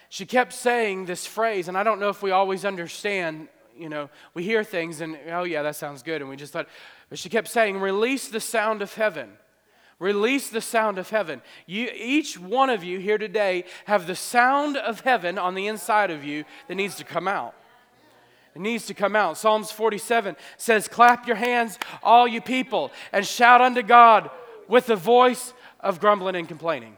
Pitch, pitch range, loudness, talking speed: 210 Hz, 180-230 Hz, -22 LUFS, 200 wpm